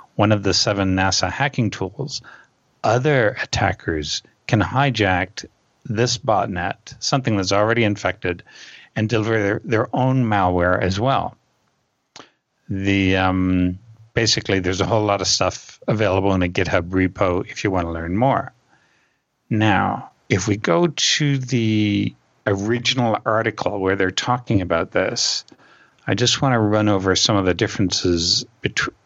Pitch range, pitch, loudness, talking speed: 95-115 Hz, 105 Hz, -20 LUFS, 140 wpm